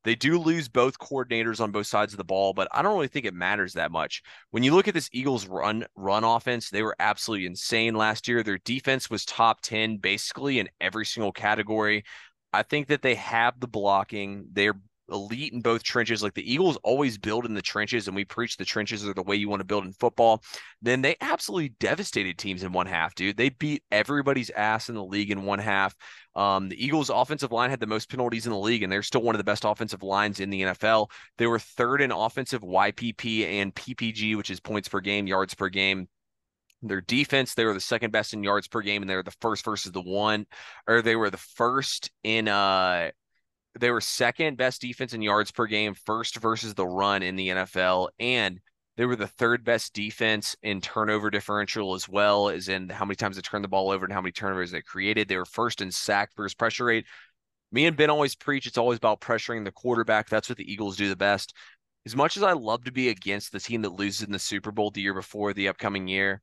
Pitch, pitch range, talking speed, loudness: 105 Hz, 100-115 Hz, 230 wpm, -26 LUFS